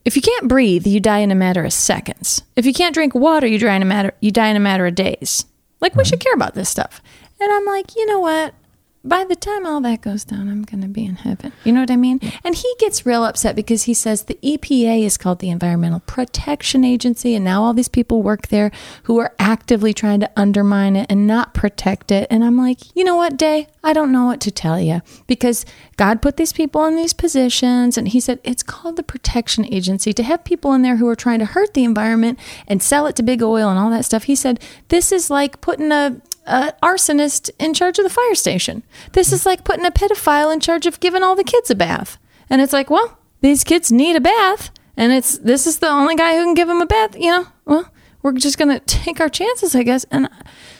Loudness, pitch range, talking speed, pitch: -16 LUFS, 220-330 Hz, 245 wpm, 255 Hz